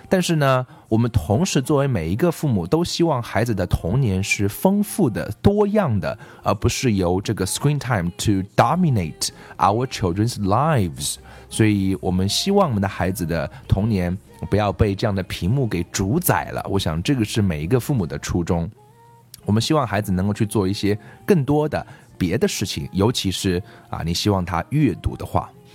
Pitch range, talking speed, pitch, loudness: 95-135 Hz, 330 characters per minute, 110 Hz, -21 LUFS